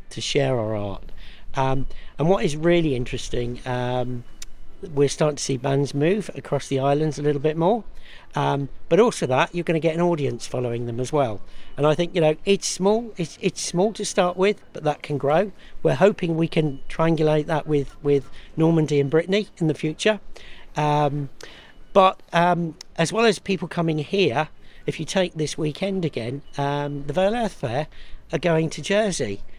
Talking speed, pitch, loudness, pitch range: 190 wpm, 155 Hz, -23 LUFS, 140-175 Hz